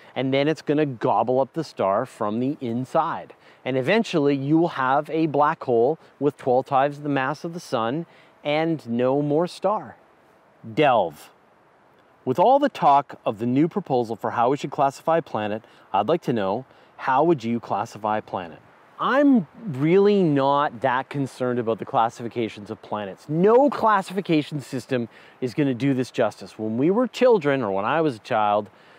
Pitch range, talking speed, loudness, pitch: 120-160 Hz, 175 wpm, -23 LUFS, 140 Hz